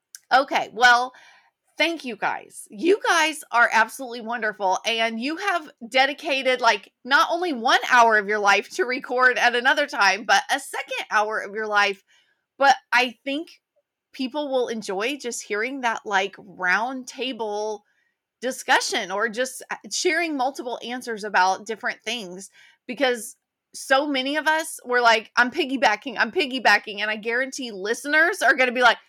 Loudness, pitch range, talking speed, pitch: -22 LUFS, 220-285 Hz, 155 wpm, 245 Hz